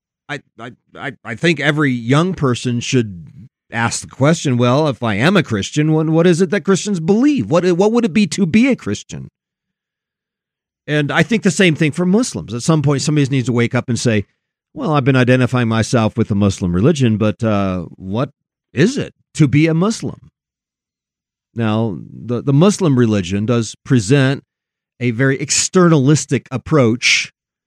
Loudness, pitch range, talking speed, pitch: -15 LUFS, 115-165 Hz, 175 wpm, 135 Hz